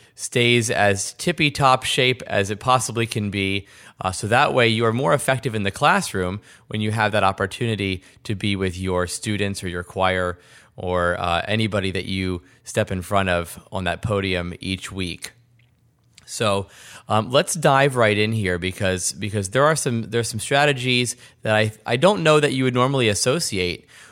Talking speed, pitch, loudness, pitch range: 180 wpm, 110 Hz, -21 LUFS, 95-125 Hz